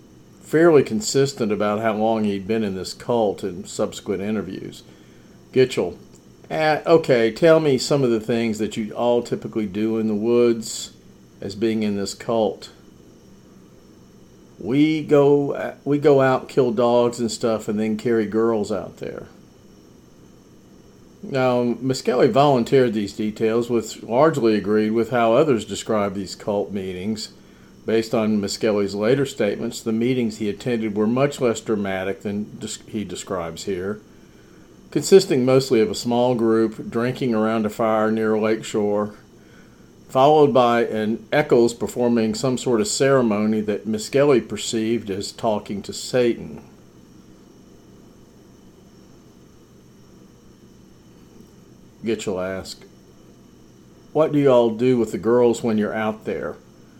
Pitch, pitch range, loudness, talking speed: 115 Hz, 105-125 Hz, -20 LUFS, 135 wpm